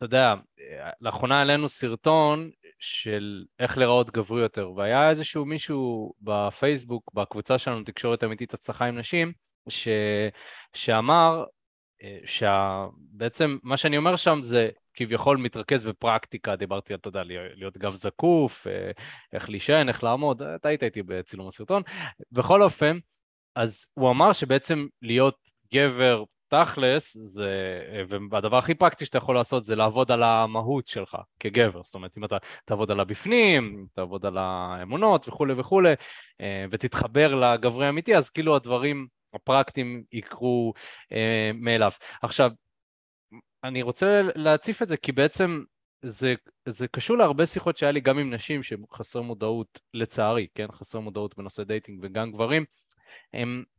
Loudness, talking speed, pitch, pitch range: -25 LUFS, 135 wpm, 120 Hz, 105-145 Hz